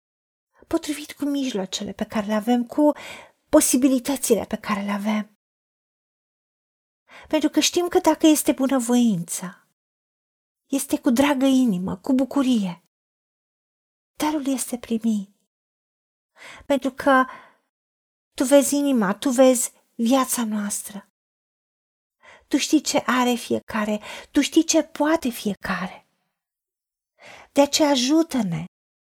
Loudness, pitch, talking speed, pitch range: -22 LUFS, 265 Hz, 105 wpm, 215-295 Hz